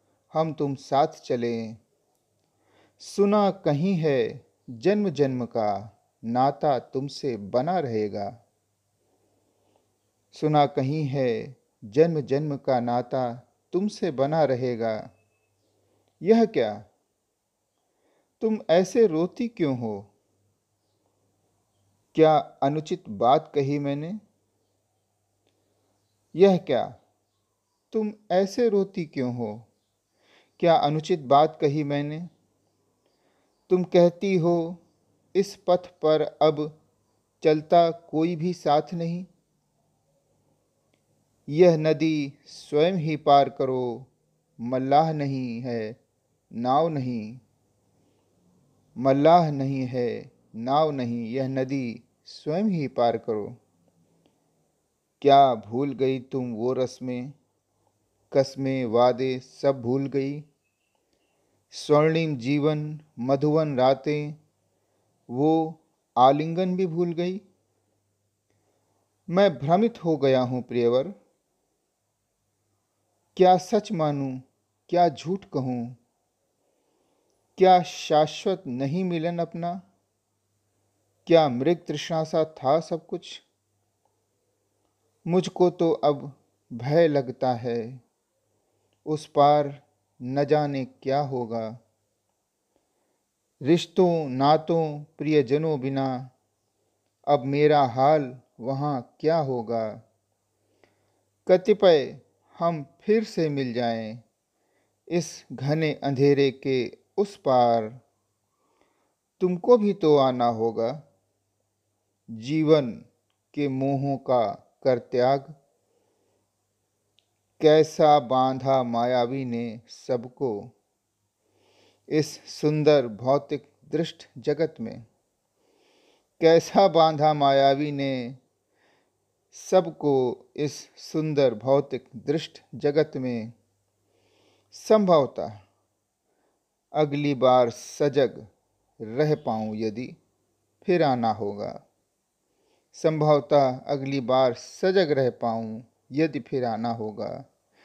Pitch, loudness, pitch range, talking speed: 135 Hz, -24 LUFS, 110-155 Hz, 85 wpm